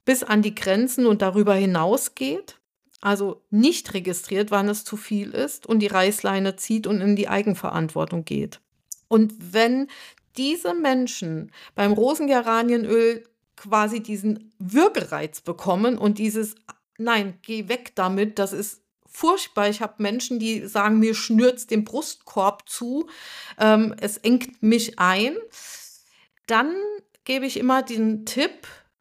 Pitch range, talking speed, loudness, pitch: 205-255 Hz, 135 wpm, -22 LUFS, 220 Hz